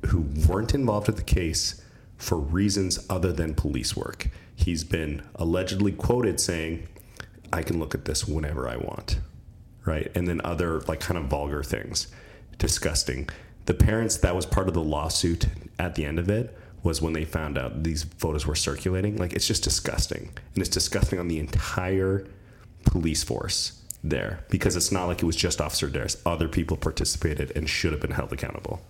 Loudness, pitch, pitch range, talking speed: -27 LUFS, 85 Hz, 80-95 Hz, 185 wpm